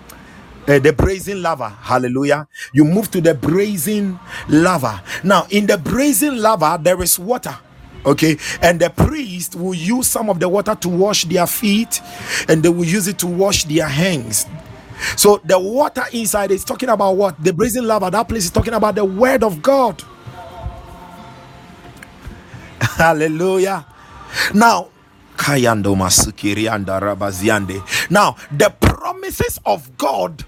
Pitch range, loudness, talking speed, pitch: 150-210 Hz, -16 LUFS, 135 wpm, 185 Hz